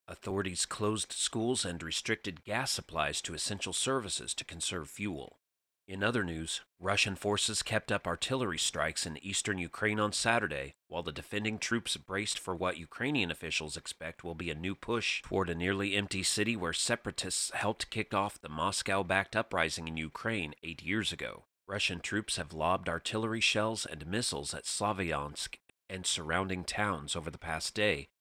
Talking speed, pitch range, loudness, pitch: 165 wpm, 85-105 Hz, -33 LUFS, 95 Hz